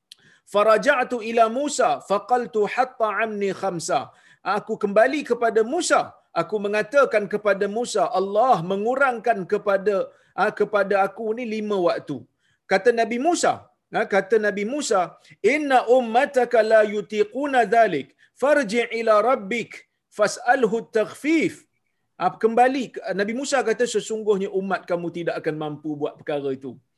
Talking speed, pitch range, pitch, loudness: 115 wpm, 195-245 Hz, 220 Hz, -22 LUFS